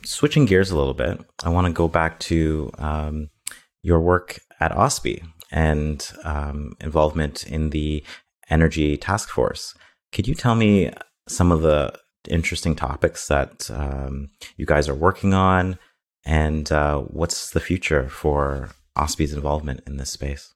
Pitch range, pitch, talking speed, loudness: 75-85 Hz, 75 Hz, 150 wpm, -22 LUFS